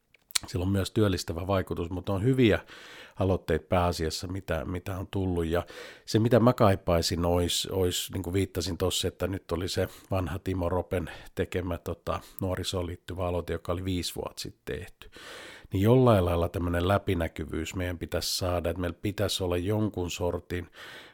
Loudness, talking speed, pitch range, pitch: -29 LUFS, 160 wpm, 85-95 Hz, 90 Hz